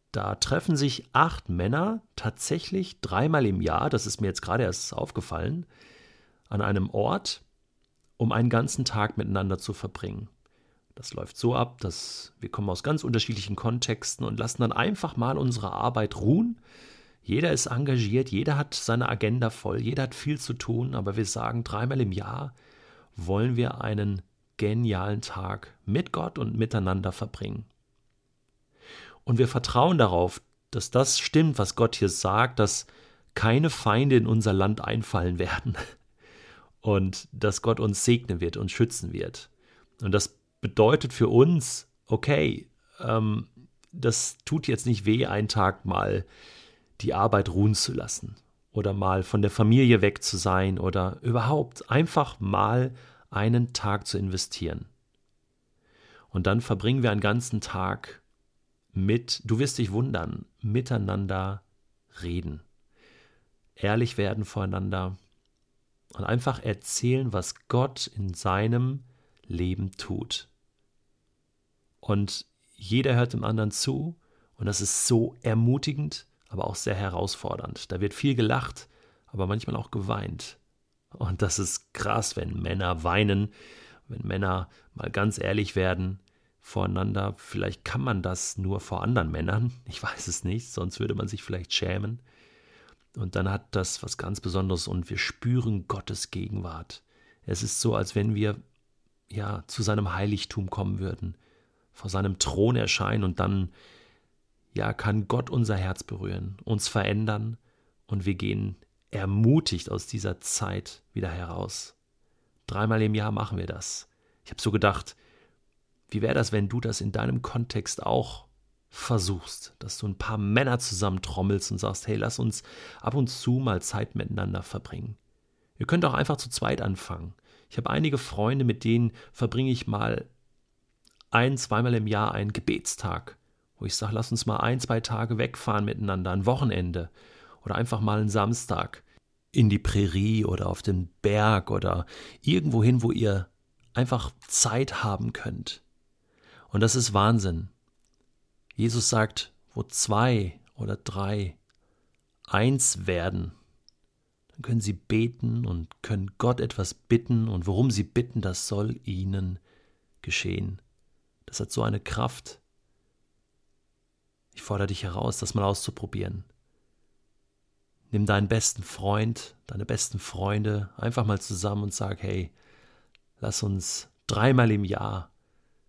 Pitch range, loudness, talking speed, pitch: 100-120 Hz, -27 LUFS, 145 wpm, 110 Hz